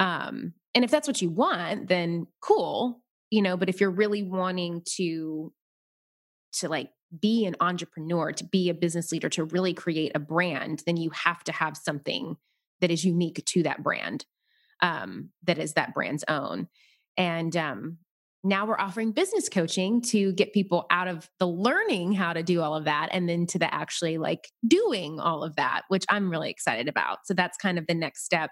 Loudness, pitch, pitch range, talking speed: -27 LUFS, 180 Hz, 165-205 Hz, 195 wpm